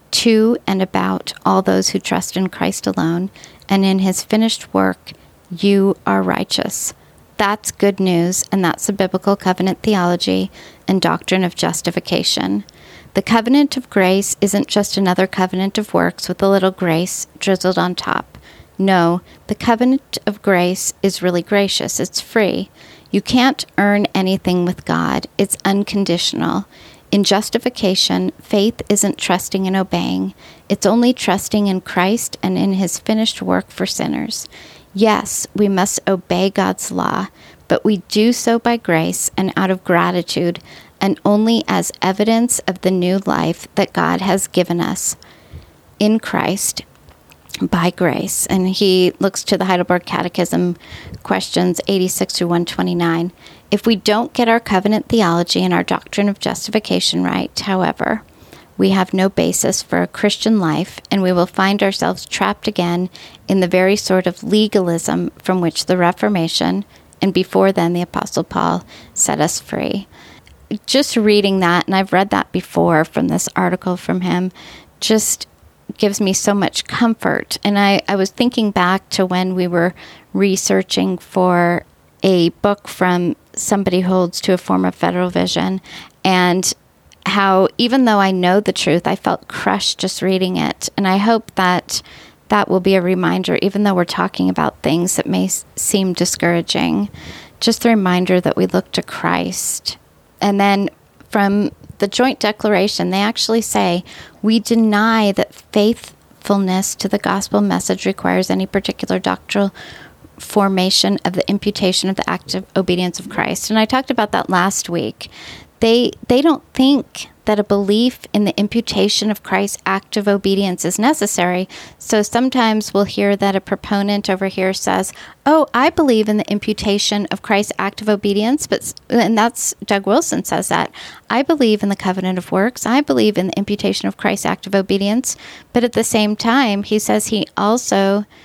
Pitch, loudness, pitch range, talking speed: 195 Hz, -16 LUFS, 180-210 Hz, 160 wpm